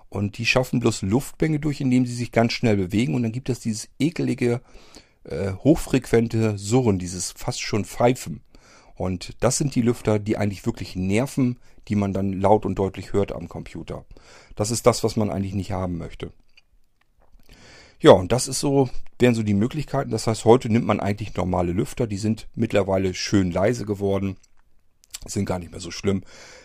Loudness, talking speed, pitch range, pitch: -23 LUFS, 180 wpm, 100-120 Hz, 110 Hz